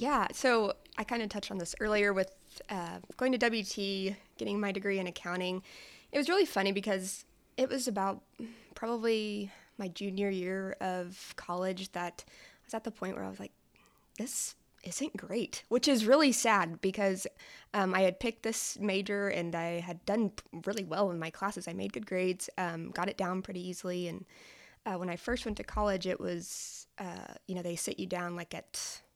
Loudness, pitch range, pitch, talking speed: -34 LUFS, 180-225 Hz, 195 Hz, 195 wpm